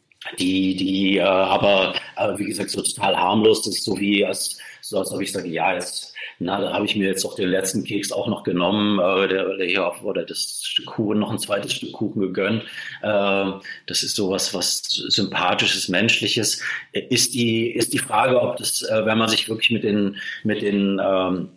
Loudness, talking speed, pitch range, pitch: -20 LUFS, 200 wpm, 95-110 Hz, 105 Hz